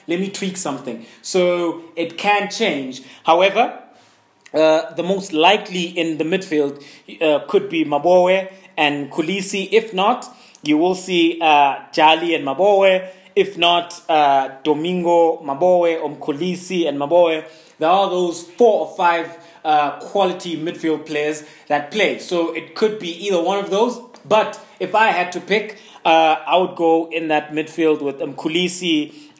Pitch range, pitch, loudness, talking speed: 155-190 Hz, 170 Hz, -18 LUFS, 150 wpm